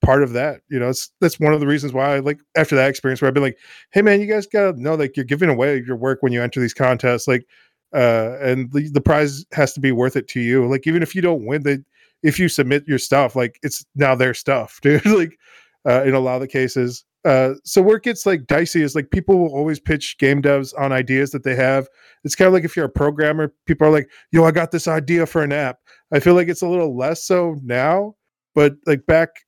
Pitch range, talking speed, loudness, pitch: 130-165 Hz, 260 wpm, -18 LUFS, 145 Hz